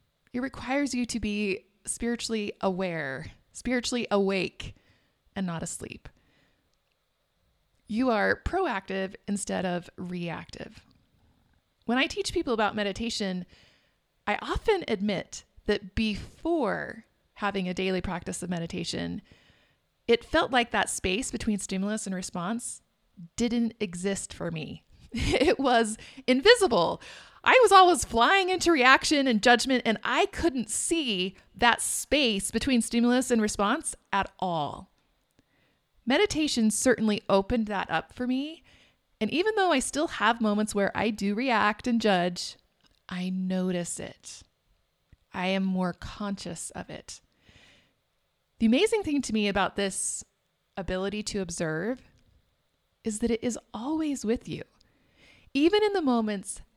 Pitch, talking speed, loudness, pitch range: 225 Hz, 130 wpm, -27 LUFS, 195-255 Hz